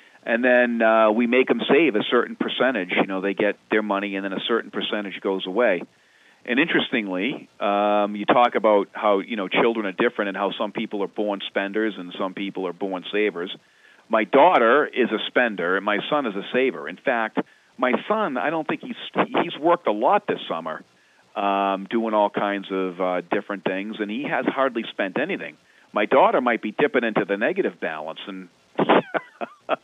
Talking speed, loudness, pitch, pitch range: 195 wpm, -22 LUFS, 100 Hz, 95-110 Hz